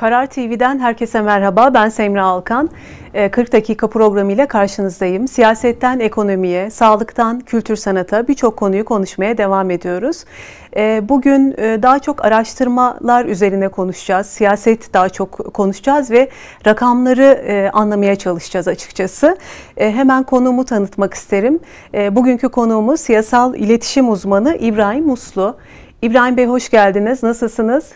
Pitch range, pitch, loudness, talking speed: 200-250 Hz, 225 Hz, -14 LUFS, 115 wpm